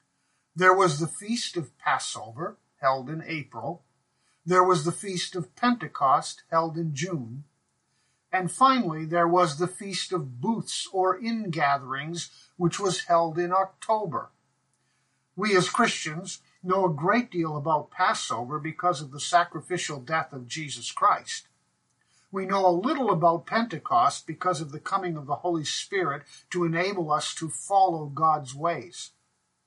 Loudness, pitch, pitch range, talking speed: -26 LUFS, 170 Hz, 150-185 Hz, 145 wpm